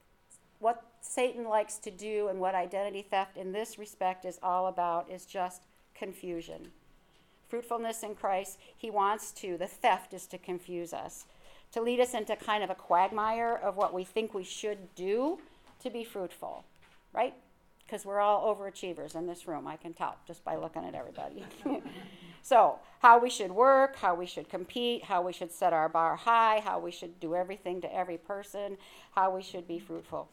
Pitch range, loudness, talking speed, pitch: 180-215 Hz, -32 LUFS, 185 wpm, 195 Hz